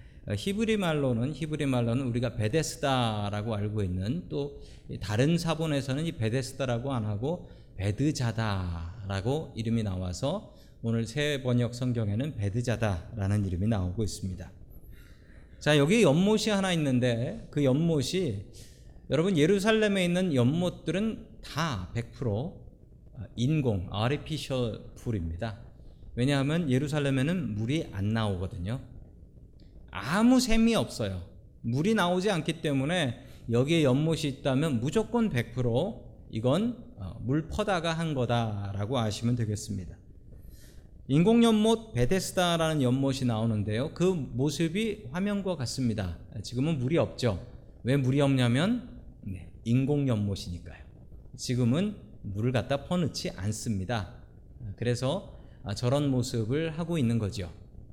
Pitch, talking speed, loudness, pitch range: 125 Hz, 275 characters per minute, -29 LUFS, 105-150 Hz